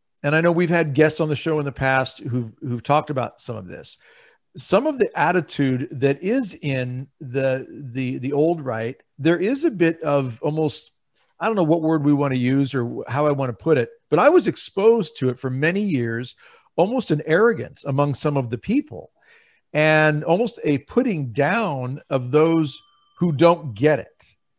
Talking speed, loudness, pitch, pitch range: 200 wpm, -21 LUFS, 150 Hz, 135-170 Hz